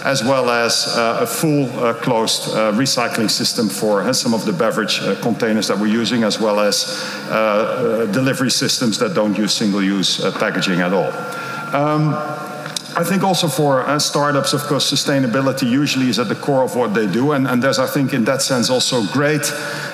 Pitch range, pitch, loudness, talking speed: 125-150 Hz, 145 Hz, -17 LUFS, 200 wpm